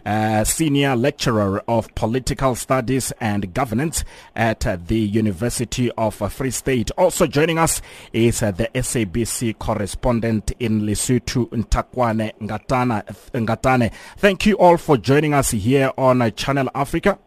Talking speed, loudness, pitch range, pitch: 135 wpm, -20 LUFS, 110-135 Hz, 120 Hz